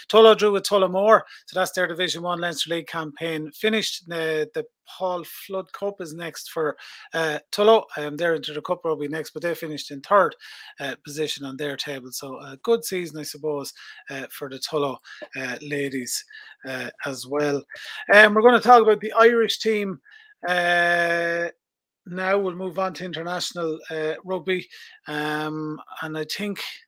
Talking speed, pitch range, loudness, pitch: 175 wpm, 150-200 Hz, -23 LUFS, 170 Hz